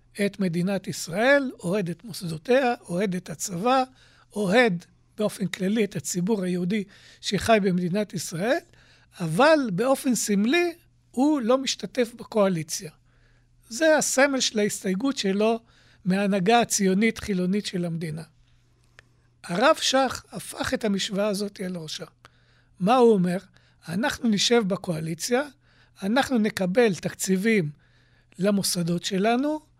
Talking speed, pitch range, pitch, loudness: 105 wpm, 175-235 Hz, 200 Hz, -24 LUFS